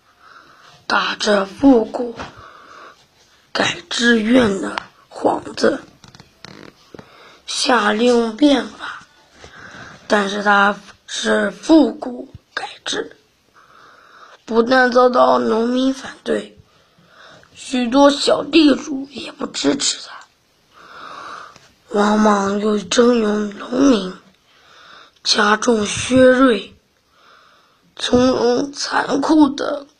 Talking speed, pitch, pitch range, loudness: 110 characters per minute, 245 Hz, 210-265 Hz, -16 LUFS